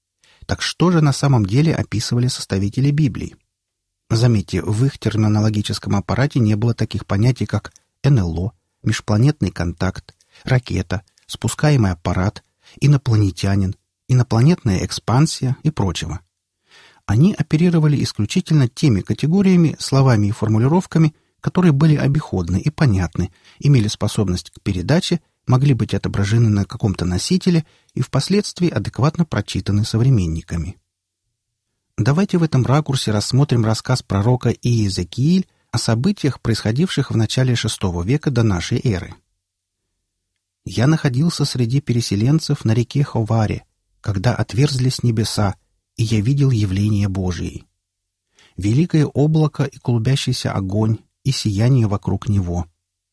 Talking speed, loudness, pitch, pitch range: 115 wpm, -18 LUFS, 115 Hz, 100-140 Hz